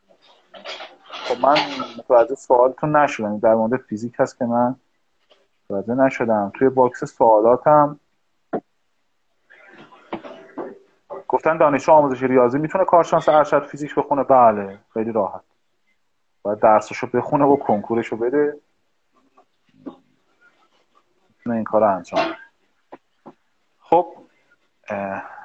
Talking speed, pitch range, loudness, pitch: 90 wpm, 115-150 Hz, -18 LUFS, 135 Hz